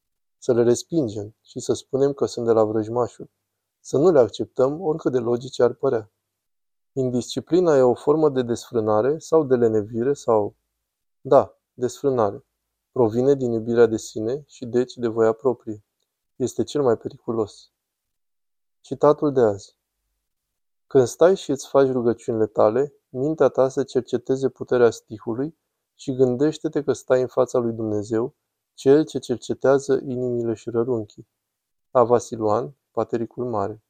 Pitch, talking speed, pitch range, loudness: 120 Hz, 140 wpm, 110-135 Hz, -22 LUFS